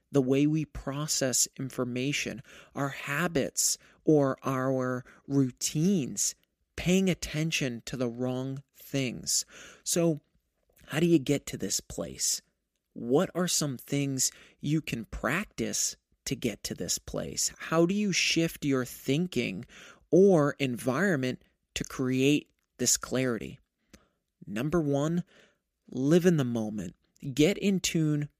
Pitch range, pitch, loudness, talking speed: 130-165 Hz, 140 Hz, -29 LUFS, 120 wpm